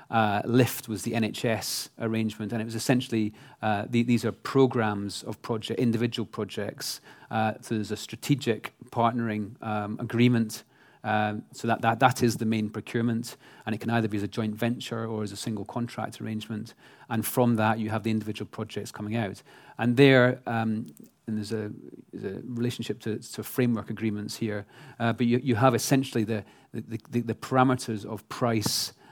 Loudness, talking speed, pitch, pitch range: -28 LUFS, 180 wpm, 115 Hz, 110-120 Hz